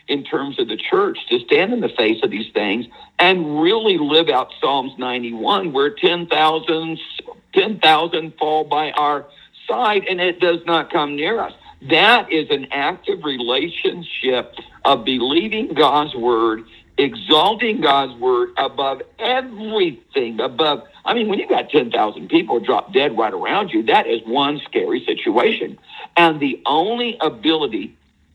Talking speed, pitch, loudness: 150 wpm, 205 Hz, -18 LUFS